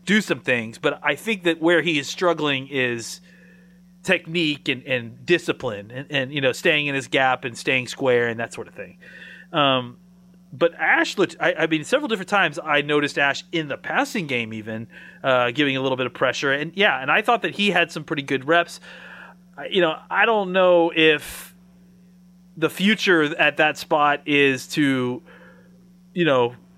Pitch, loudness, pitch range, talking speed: 160 Hz, -21 LUFS, 135-180 Hz, 190 wpm